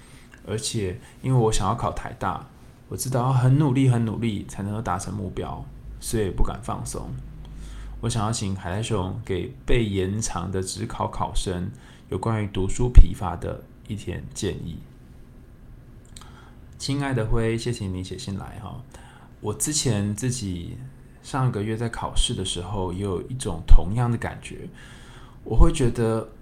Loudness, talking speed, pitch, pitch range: -26 LUFS, 225 characters per minute, 110 Hz, 95-120 Hz